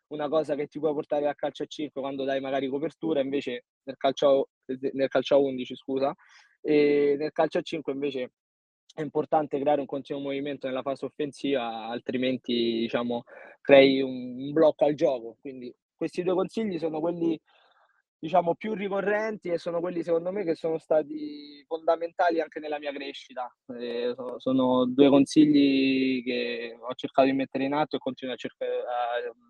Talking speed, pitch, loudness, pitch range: 170 wpm, 140 Hz, -27 LUFS, 130-155 Hz